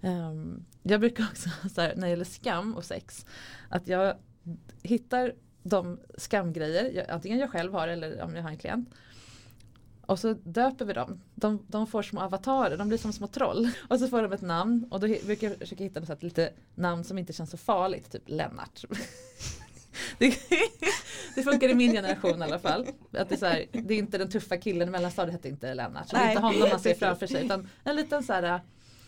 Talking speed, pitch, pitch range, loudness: 215 wpm, 195 Hz, 170-230 Hz, -29 LUFS